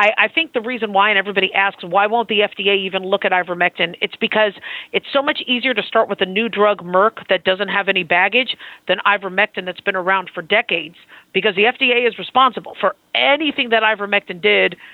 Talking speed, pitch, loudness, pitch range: 205 wpm, 200 Hz, -17 LUFS, 190-225 Hz